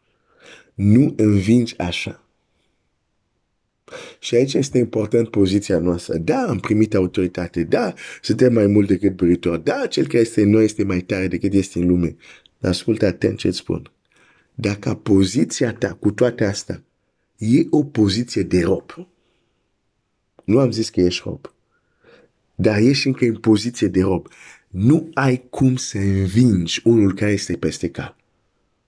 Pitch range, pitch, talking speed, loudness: 95-120 Hz, 105 Hz, 145 wpm, -19 LUFS